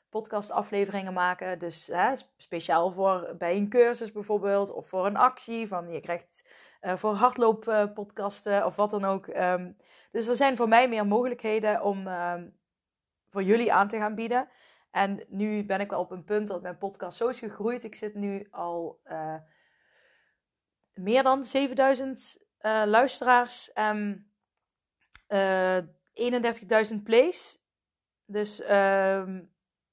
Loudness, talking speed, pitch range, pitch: -27 LUFS, 145 wpm, 190-230 Hz, 210 Hz